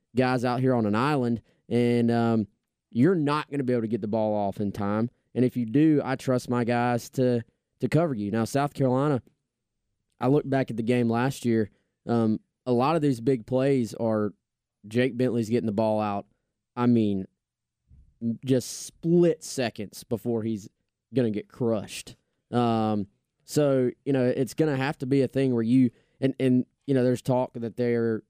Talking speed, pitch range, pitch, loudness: 195 wpm, 115-130 Hz, 120 Hz, -26 LUFS